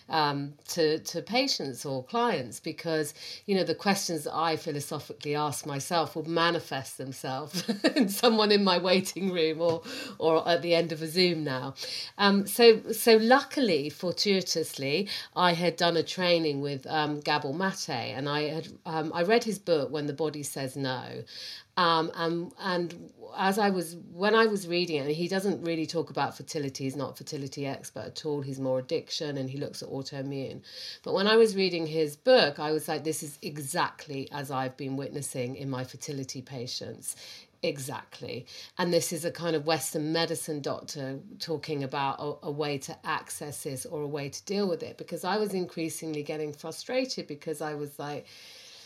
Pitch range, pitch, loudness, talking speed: 145-175 Hz, 160 Hz, -29 LUFS, 185 wpm